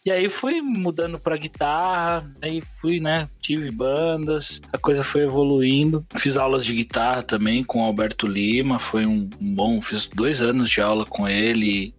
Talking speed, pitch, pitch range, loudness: 175 wpm, 140 Hz, 115-165 Hz, -22 LUFS